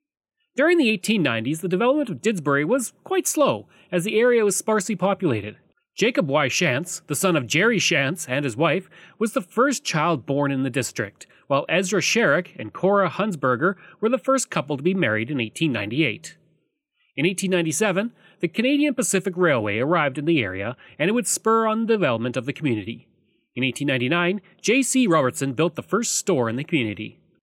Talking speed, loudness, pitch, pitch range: 175 wpm, -22 LUFS, 180 Hz, 145-220 Hz